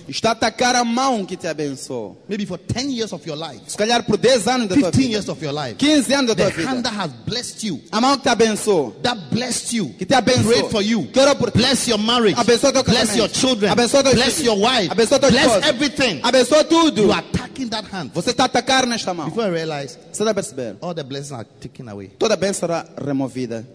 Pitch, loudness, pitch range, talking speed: 220 Hz, -18 LUFS, 170-250 Hz, 160 wpm